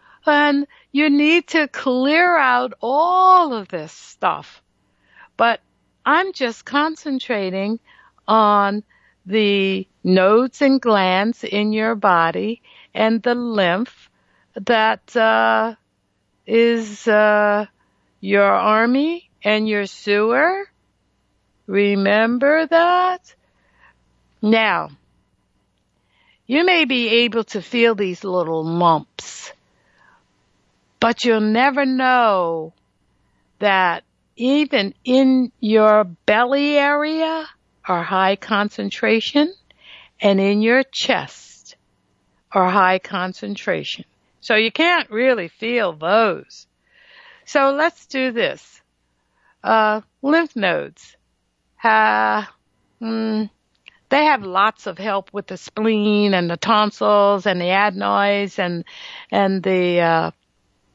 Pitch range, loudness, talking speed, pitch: 190-260 Hz, -18 LUFS, 100 wpm, 215 Hz